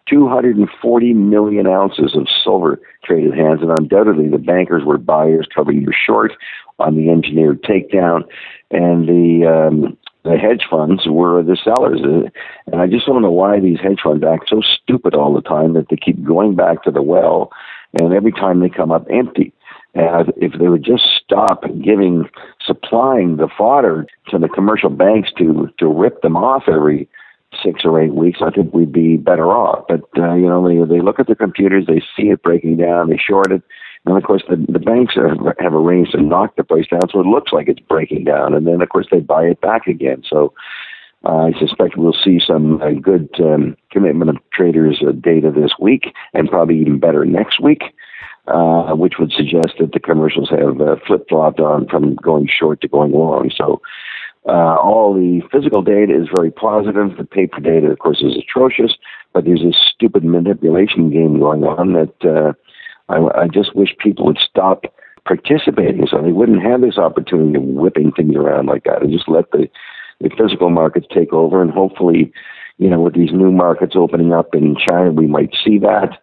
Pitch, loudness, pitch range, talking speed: 85 Hz, -13 LUFS, 80-95 Hz, 200 wpm